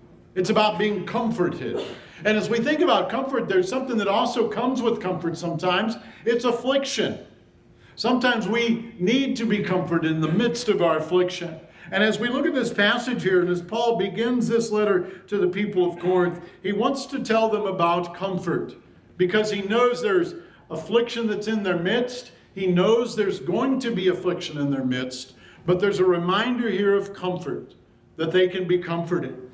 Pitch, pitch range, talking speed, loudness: 200 Hz, 180-230 Hz, 180 wpm, -23 LUFS